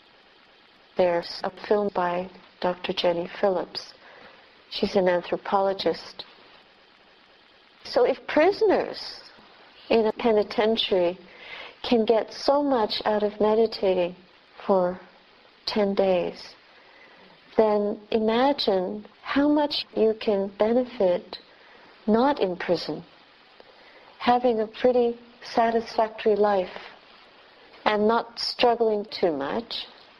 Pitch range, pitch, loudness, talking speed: 185-235 Hz, 215 Hz, -24 LUFS, 90 wpm